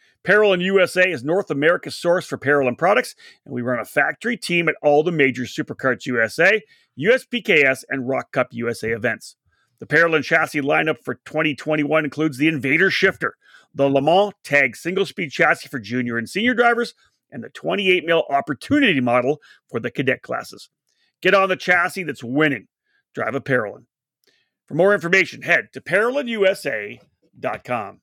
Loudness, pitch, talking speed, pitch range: -19 LUFS, 160 Hz, 160 wpm, 140-190 Hz